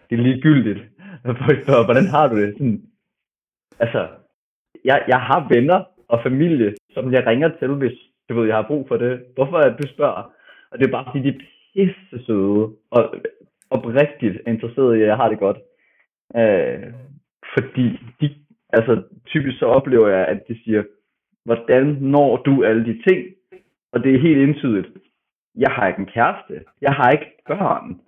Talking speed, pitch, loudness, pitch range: 170 wpm, 130 Hz, -18 LUFS, 115-150 Hz